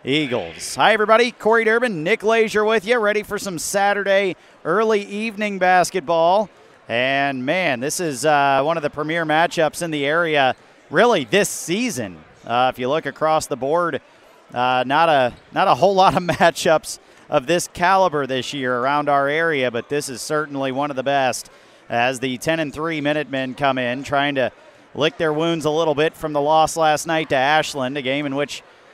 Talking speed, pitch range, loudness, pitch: 190 wpm, 140-180 Hz, -19 LUFS, 155 Hz